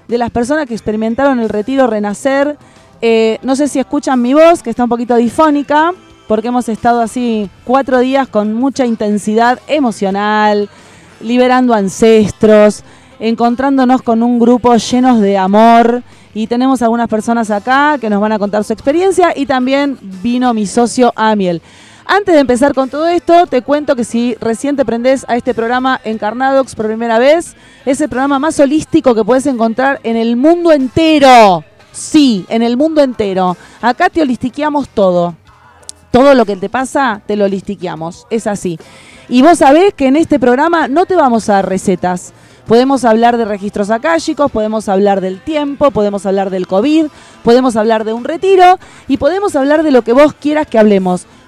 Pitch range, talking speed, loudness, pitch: 220-280 Hz, 175 wpm, -11 LUFS, 240 Hz